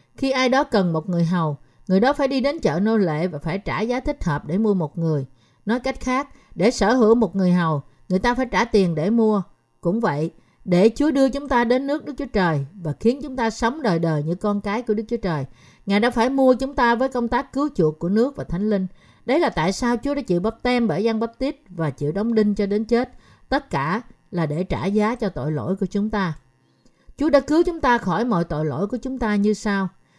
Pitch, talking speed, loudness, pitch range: 210 Hz, 255 wpm, -21 LUFS, 170-245 Hz